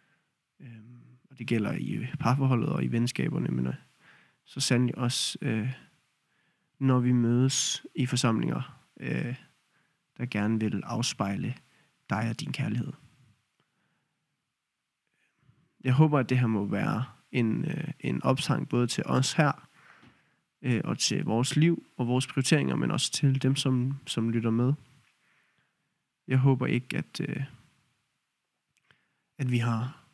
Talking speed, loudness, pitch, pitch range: 120 wpm, -28 LUFS, 125 Hz, 115-140 Hz